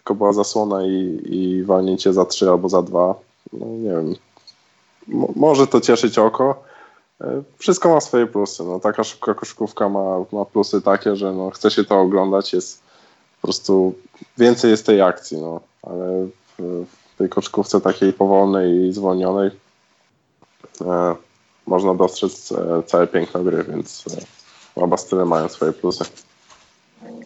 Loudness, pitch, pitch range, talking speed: -18 LUFS, 95 Hz, 90-110 Hz, 150 wpm